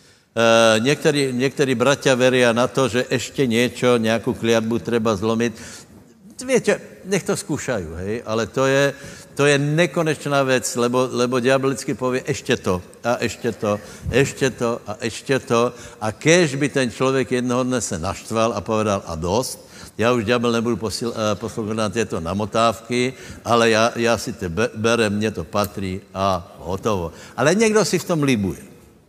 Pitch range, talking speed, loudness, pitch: 110-135 Hz, 160 wpm, -20 LUFS, 120 Hz